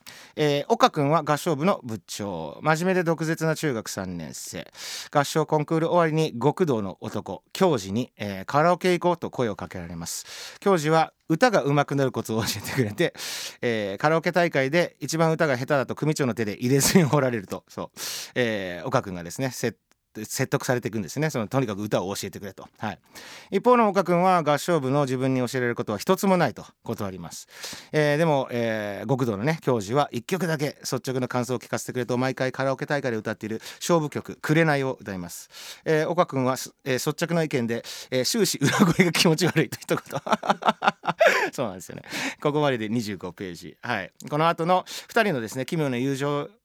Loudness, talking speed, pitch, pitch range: -25 LUFS, 375 characters per minute, 140 Hz, 120-165 Hz